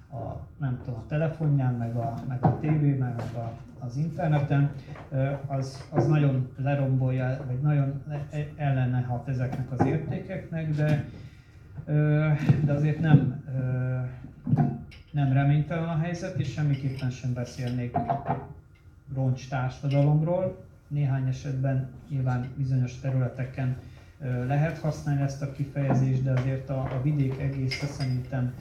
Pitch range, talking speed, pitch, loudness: 130-145 Hz, 115 wpm, 135 Hz, -28 LUFS